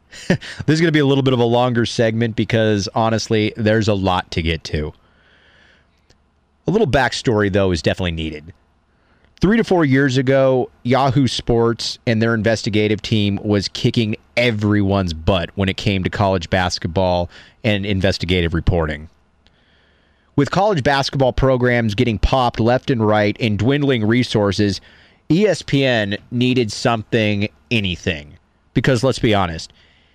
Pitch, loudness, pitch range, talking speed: 105 Hz, -18 LUFS, 90-120 Hz, 140 wpm